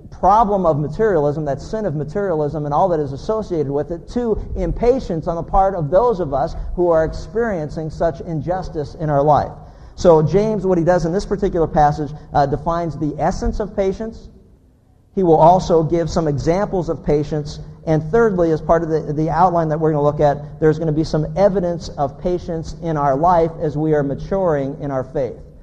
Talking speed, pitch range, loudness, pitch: 200 wpm, 150-185 Hz, -18 LUFS, 160 Hz